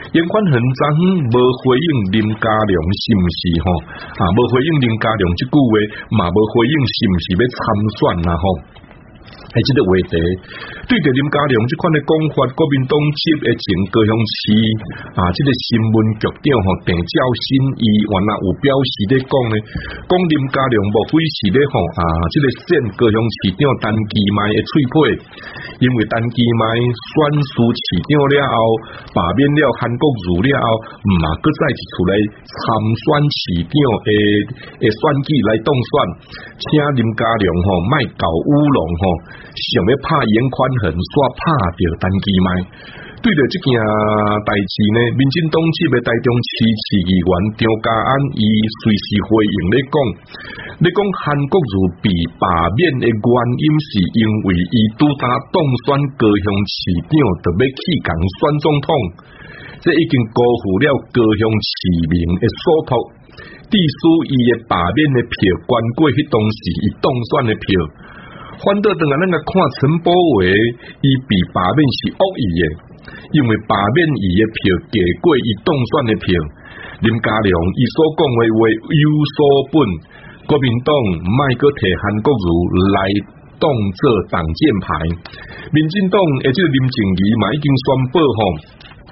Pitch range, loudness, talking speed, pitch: 100-145 Hz, -15 LUFS, 215 characters per minute, 115 Hz